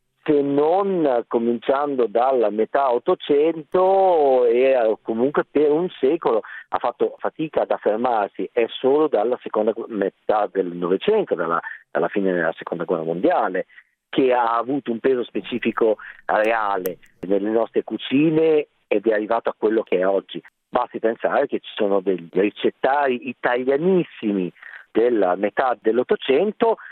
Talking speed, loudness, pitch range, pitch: 130 wpm, -21 LUFS, 105-160 Hz, 125 Hz